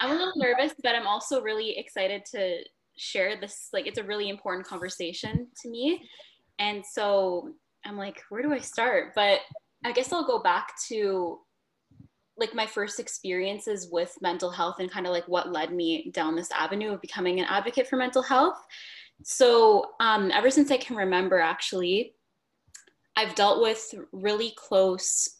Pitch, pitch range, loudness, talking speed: 210 Hz, 185-260 Hz, -27 LUFS, 170 wpm